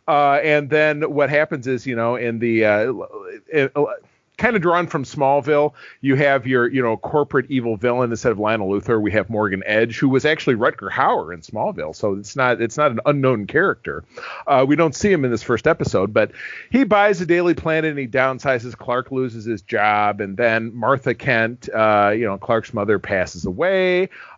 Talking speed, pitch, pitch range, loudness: 200 wpm, 130 Hz, 115-150 Hz, -19 LUFS